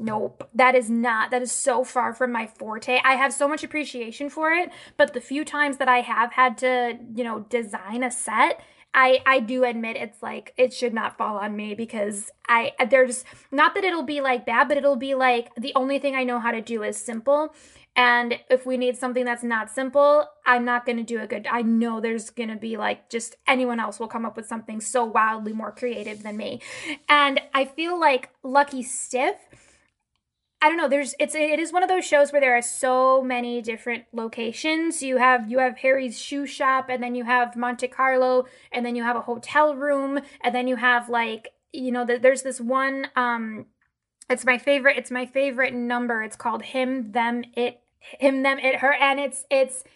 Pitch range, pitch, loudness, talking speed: 235-275 Hz, 255 Hz, -23 LUFS, 215 wpm